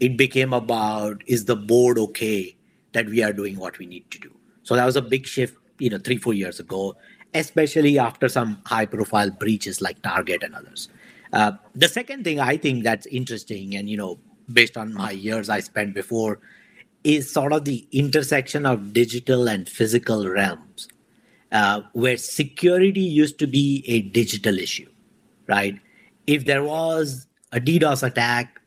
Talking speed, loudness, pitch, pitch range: 170 wpm, -22 LUFS, 120 Hz, 105-145 Hz